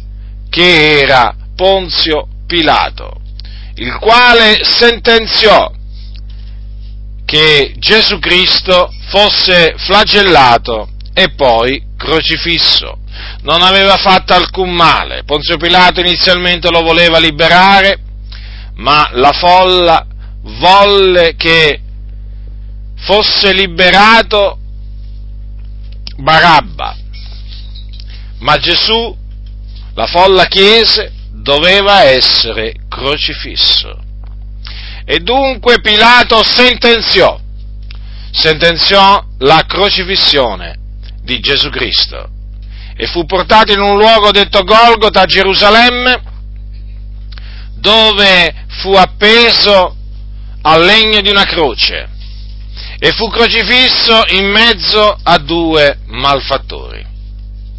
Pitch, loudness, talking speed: 160 Hz, -7 LUFS, 80 wpm